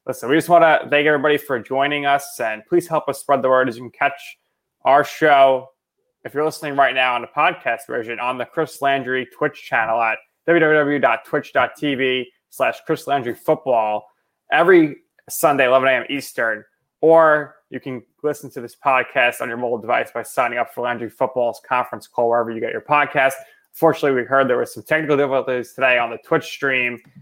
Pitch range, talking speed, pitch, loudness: 125-150 Hz, 190 wpm, 135 Hz, -18 LUFS